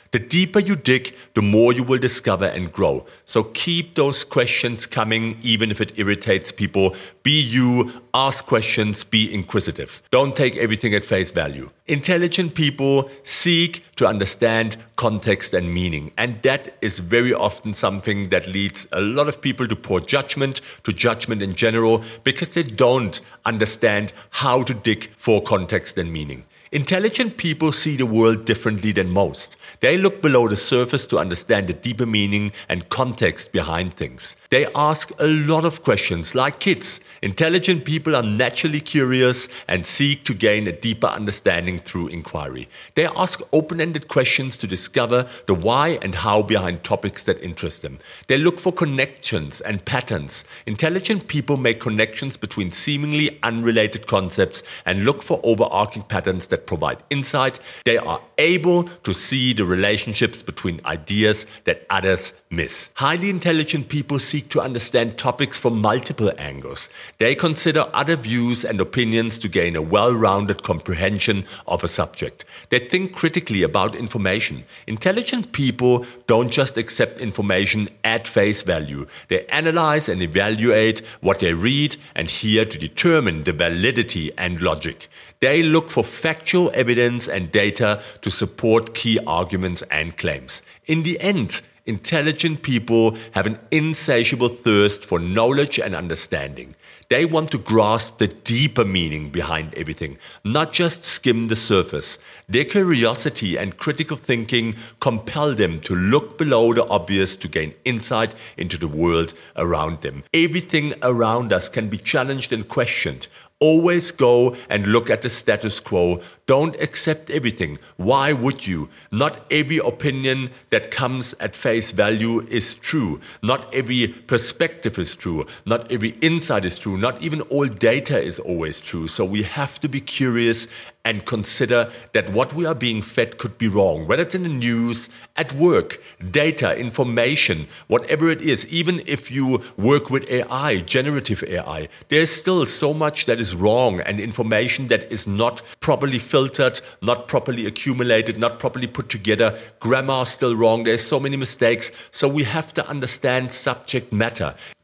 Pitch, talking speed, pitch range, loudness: 120 Hz, 155 wpm, 105-145 Hz, -20 LUFS